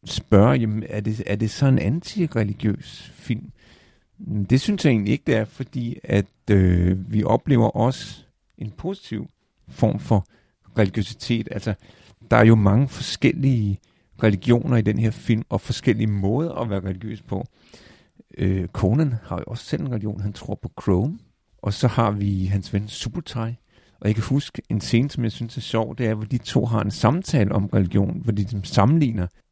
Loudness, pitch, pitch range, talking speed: -22 LUFS, 110 Hz, 100-120 Hz, 185 wpm